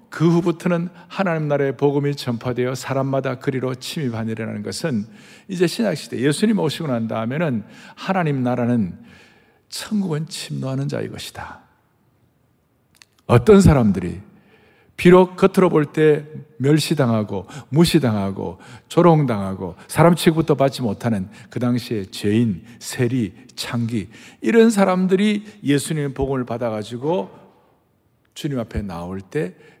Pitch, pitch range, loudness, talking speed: 140 Hz, 120-170 Hz, -20 LUFS, 285 characters per minute